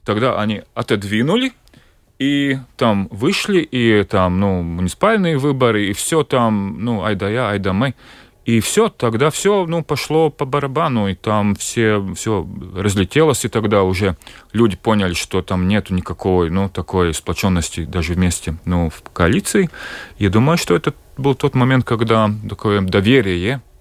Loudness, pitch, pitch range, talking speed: -17 LUFS, 110 Hz, 95-130 Hz, 155 wpm